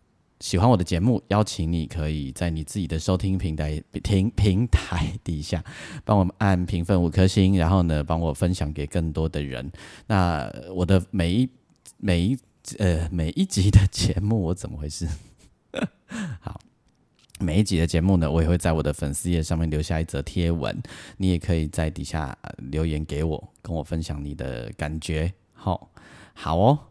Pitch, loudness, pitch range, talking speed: 85 Hz, -25 LUFS, 80-95 Hz, 250 characters per minute